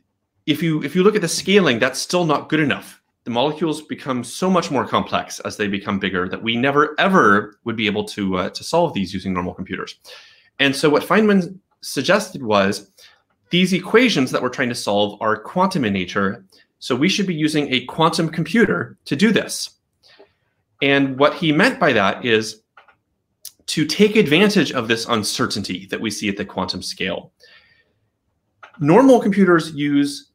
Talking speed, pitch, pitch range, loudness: 180 wpm, 140 Hz, 105-165 Hz, -18 LUFS